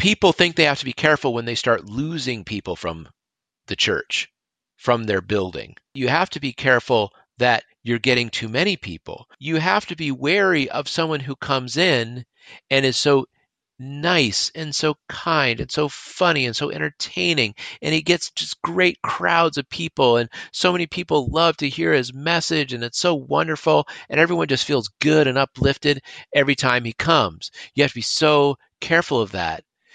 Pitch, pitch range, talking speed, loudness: 145 Hz, 125-165 Hz, 185 wpm, -20 LUFS